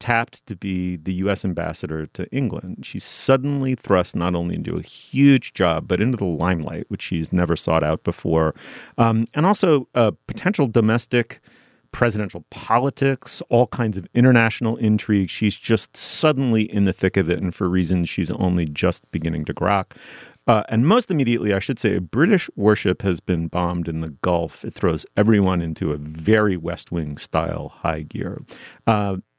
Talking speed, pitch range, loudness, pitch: 175 wpm, 85-120 Hz, -20 LUFS, 100 Hz